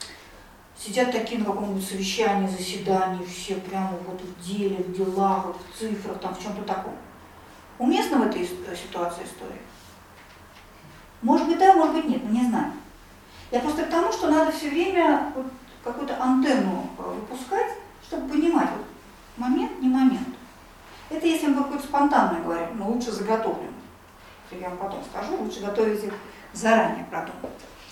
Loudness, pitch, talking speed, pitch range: -25 LUFS, 230 Hz, 150 wpm, 195-285 Hz